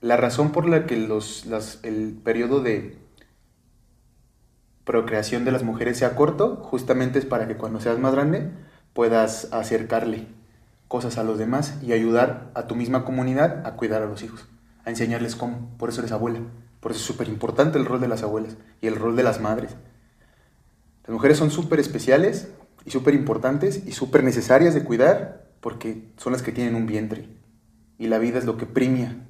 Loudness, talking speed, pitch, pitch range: -23 LUFS, 185 wpm, 115 Hz, 110-130 Hz